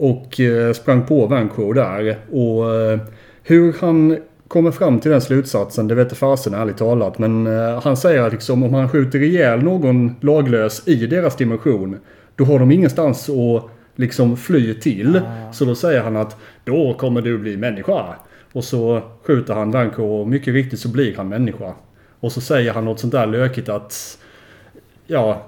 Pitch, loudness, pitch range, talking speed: 120 Hz, -17 LUFS, 110-140 Hz, 170 wpm